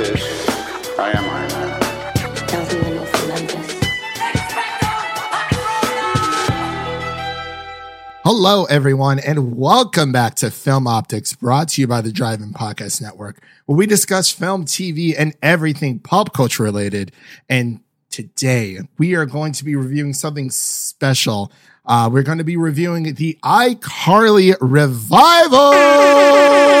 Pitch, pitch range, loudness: 145 Hz, 130-180 Hz, -15 LUFS